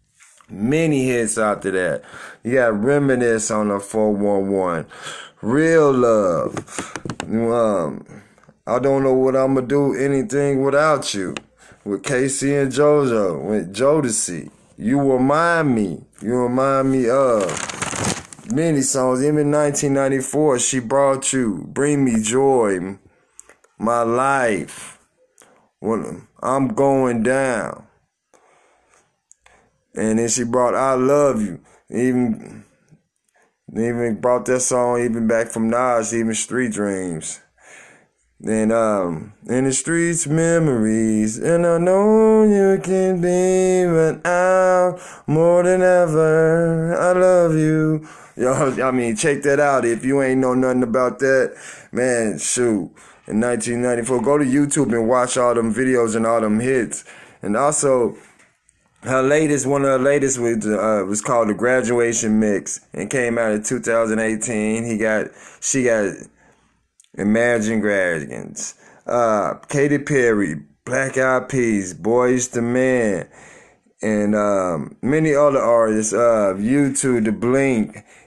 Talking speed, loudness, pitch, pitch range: 125 wpm, -18 LUFS, 130 Hz, 115-145 Hz